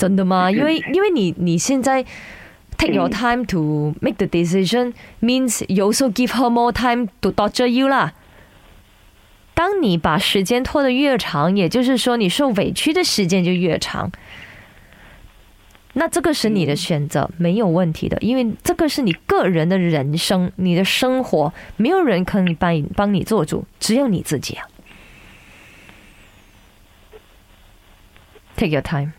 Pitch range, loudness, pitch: 150-245 Hz, -18 LUFS, 190 Hz